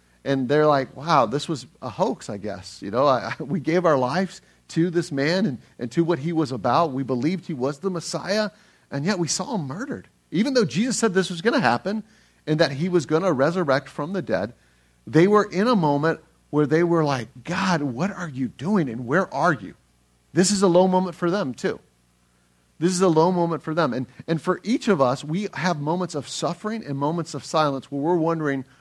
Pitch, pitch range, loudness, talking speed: 165 Hz, 135-185 Hz, -23 LUFS, 230 wpm